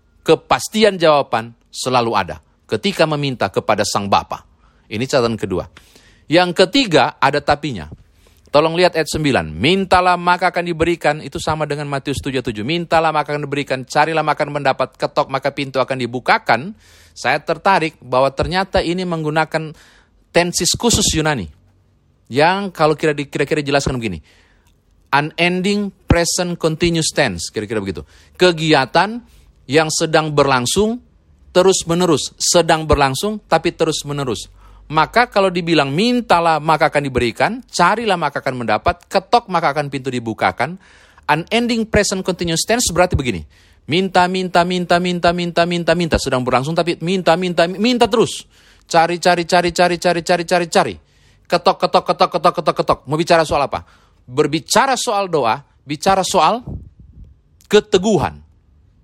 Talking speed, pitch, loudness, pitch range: 135 wpm, 160 Hz, -16 LUFS, 135-180 Hz